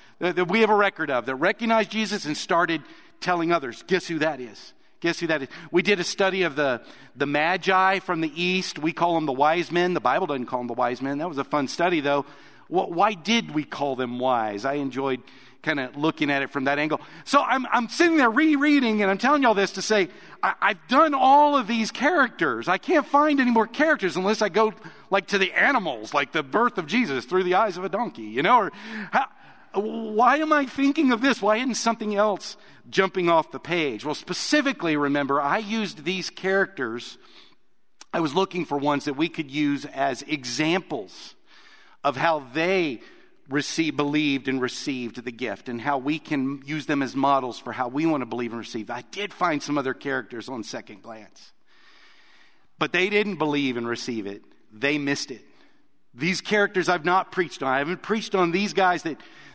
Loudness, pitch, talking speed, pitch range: -24 LUFS, 170 Hz, 210 wpm, 140-210 Hz